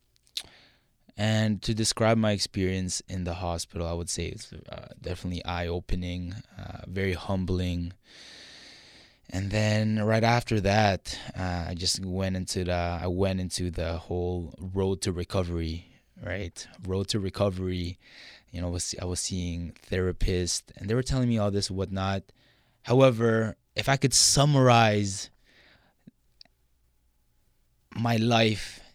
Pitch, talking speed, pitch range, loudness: 95 Hz, 135 wpm, 90-110 Hz, -27 LUFS